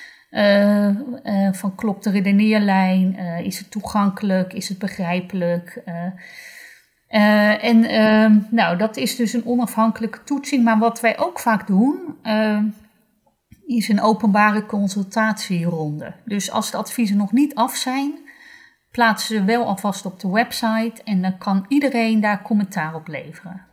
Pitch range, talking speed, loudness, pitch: 195-230 Hz, 150 wpm, -19 LUFS, 215 Hz